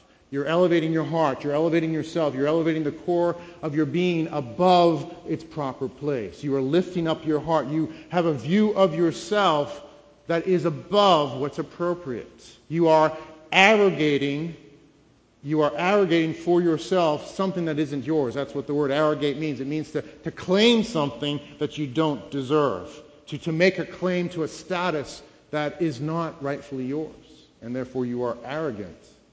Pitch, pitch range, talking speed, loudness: 155 Hz, 145-170 Hz, 165 wpm, -24 LUFS